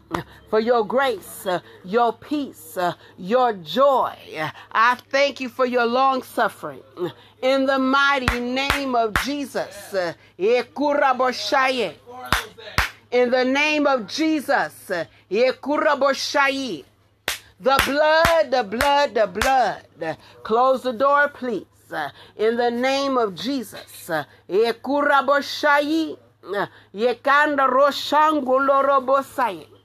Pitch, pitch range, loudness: 270 Hz, 240-285 Hz, -21 LUFS